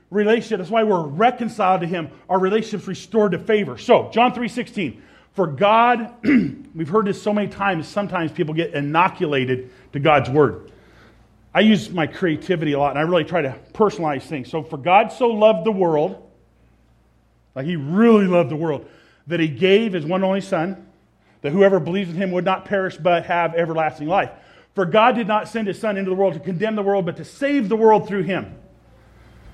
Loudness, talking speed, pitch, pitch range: -19 LUFS, 200 wpm, 185 Hz, 155-210 Hz